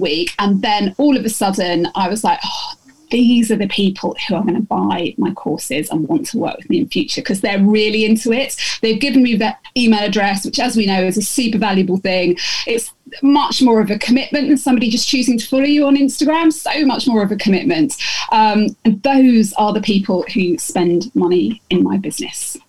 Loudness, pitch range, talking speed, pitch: -15 LUFS, 205-275 Hz, 220 wpm, 230 Hz